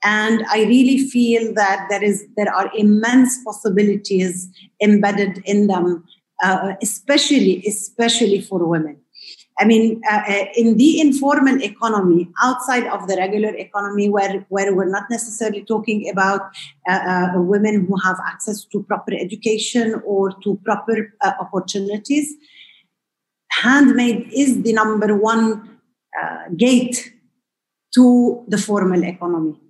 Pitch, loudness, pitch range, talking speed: 210 Hz, -17 LUFS, 195-230 Hz, 125 wpm